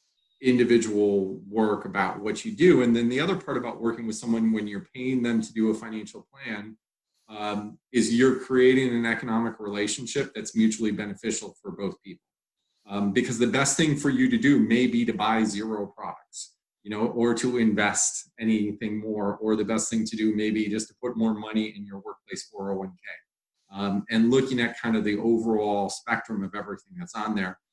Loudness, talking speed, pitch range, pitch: -25 LUFS, 195 wpm, 105-120 Hz, 110 Hz